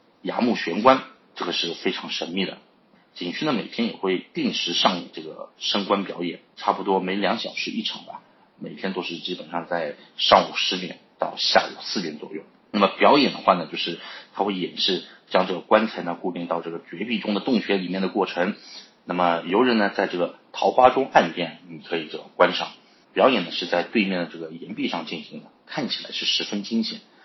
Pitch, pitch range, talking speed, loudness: 95 Hz, 85-110 Hz, 300 characters per minute, -23 LUFS